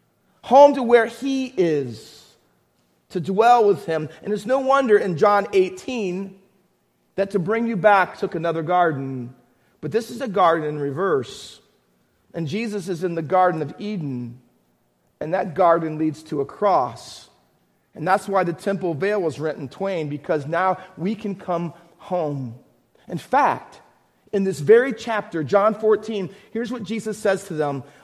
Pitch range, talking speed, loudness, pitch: 155-210 Hz, 165 wpm, -21 LUFS, 185 Hz